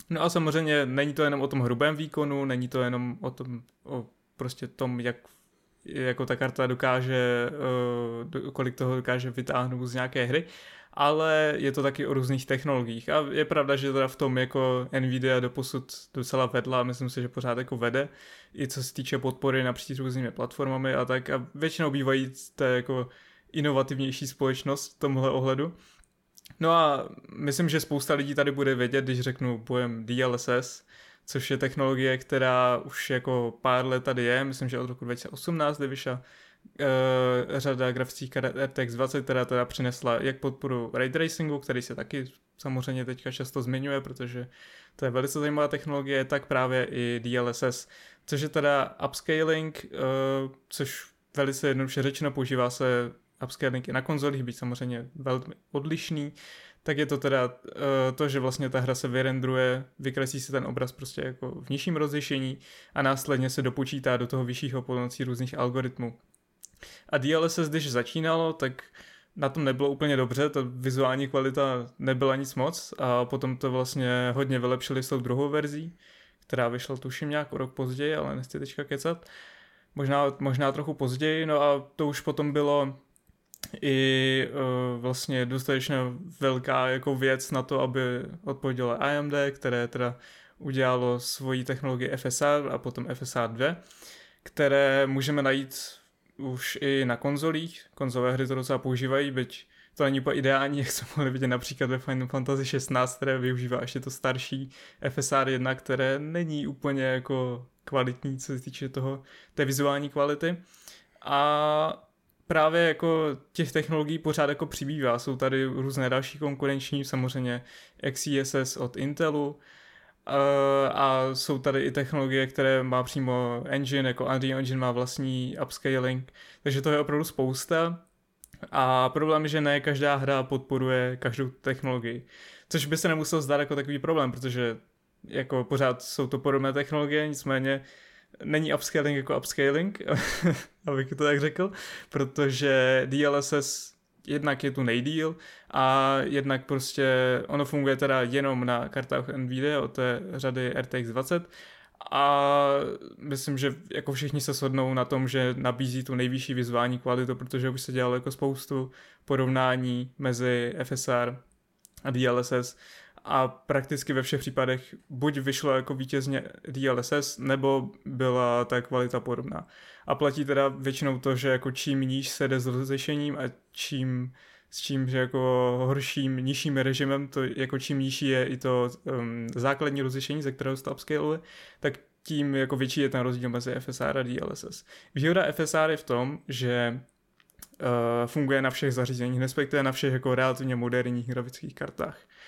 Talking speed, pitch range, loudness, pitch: 155 wpm, 130-140 Hz, -28 LUFS, 135 Hz